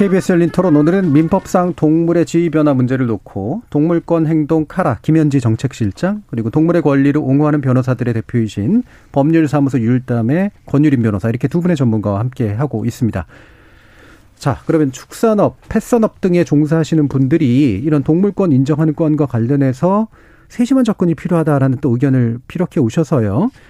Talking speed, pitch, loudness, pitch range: 380 characters per minute, 150 Hz, -15 LUFS, 130-170 Hz